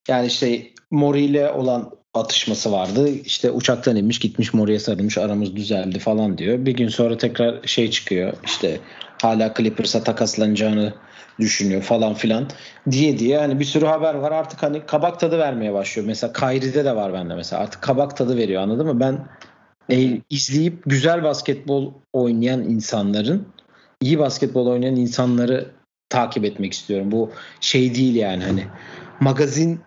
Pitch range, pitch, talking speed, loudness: 110-140 Hz, 125 Hz, 150 wpm, -20 LUFS